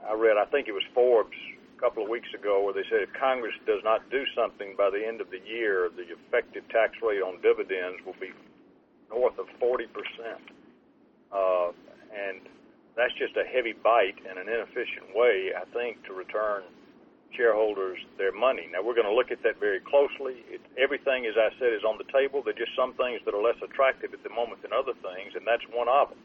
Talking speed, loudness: 215 wpm, -28 LUFS